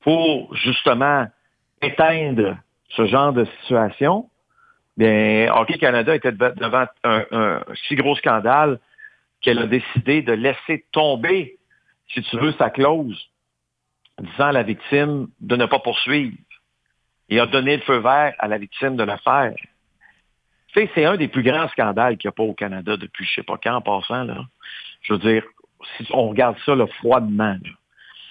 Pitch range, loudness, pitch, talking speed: 110-145 Hz, -19 LUFS, 125 Hz, 175 wpm